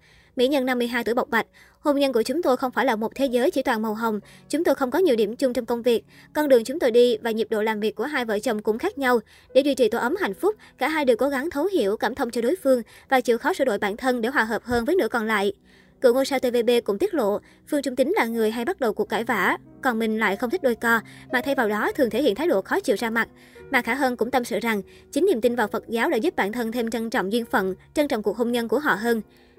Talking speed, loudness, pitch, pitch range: 305 wpm, -23 LUFS, 240 Hz, 225-265 Hz